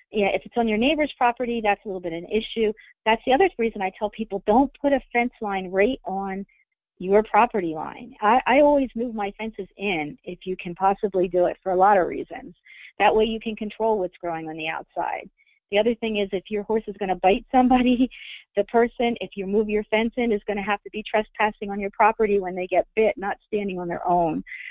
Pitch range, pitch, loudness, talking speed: 195-235 Hz, 210 Hz, -23 LUFS, 240 wpm